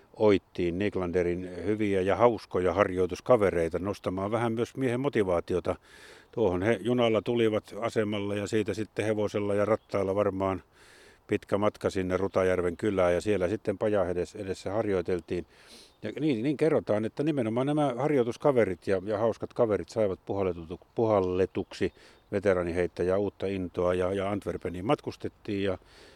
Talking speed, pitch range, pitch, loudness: 130 wpm, 90-110 Hz, 100 Hz, -29 LUFS